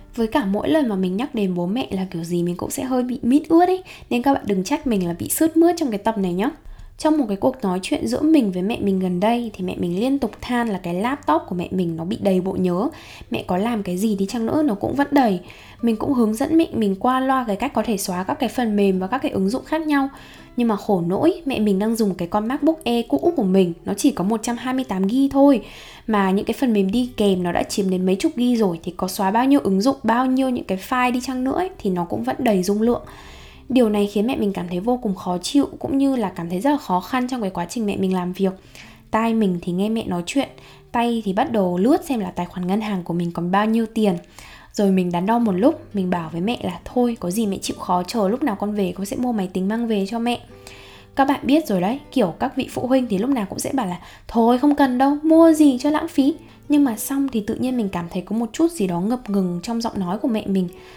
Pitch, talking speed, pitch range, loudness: 220 Hz, 285 wpm, 190-260 Hz, -21 LUFS